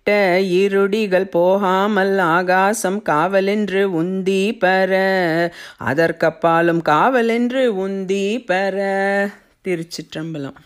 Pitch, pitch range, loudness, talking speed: 190 Hz, 170-195 Hz, -17 LUFS, 60 wpm